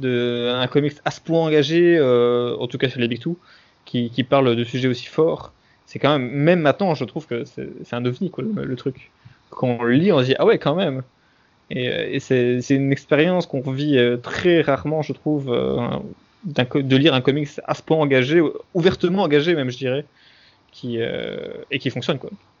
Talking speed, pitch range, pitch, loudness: 220 wpm, 125-160 Hz, 135 Hz, -20 LUFS